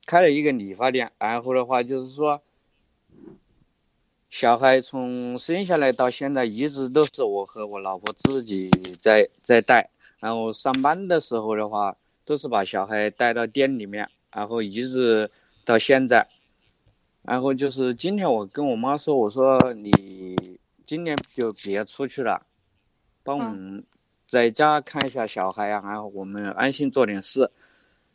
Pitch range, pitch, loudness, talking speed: 105-135 Hz, 125 Hz, -23 LUFS, 220 characters per minute